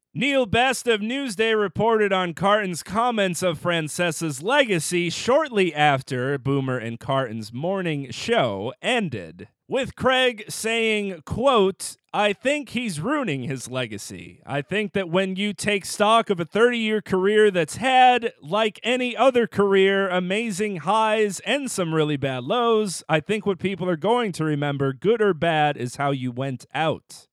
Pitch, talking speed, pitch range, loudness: 195 Hz, 150 wpm, 155-225 Hz, -22 LUFS